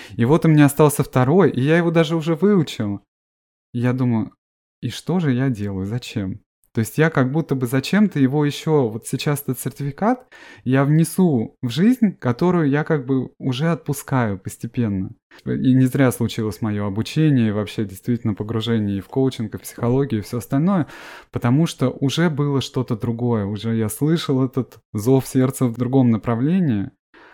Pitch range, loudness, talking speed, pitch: 115-150 Hz, -20 LUFS, 175 wpm, 130 Hz